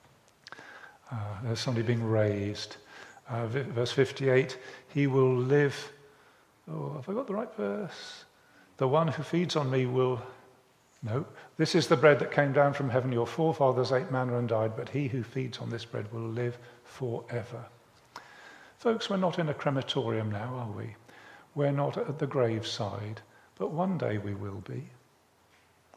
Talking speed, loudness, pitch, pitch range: 165 wpm, -30 LUFS, 130 Hz, 115-145 Hz